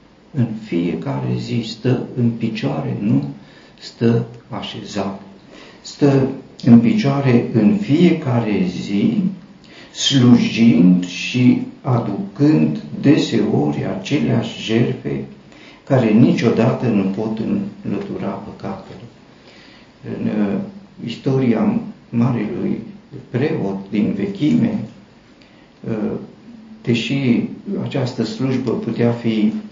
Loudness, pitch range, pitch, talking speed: -18 LUFS, 100-140 Hz, 120 Hz, 80 wpm